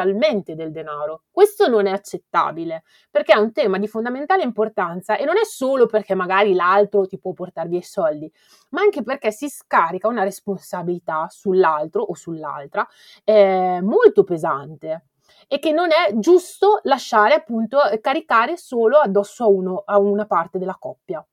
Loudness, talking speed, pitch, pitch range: -19 LUFS, 155 wpm, 205 Hz, 180-270 Hz